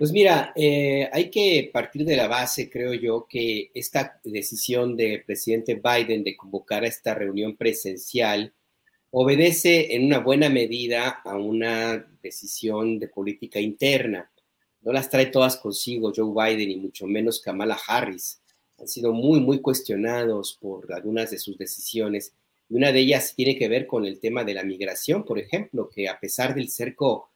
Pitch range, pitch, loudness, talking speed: 105-130 Hz, 115 Hz, -24 LUFS, 165 wpm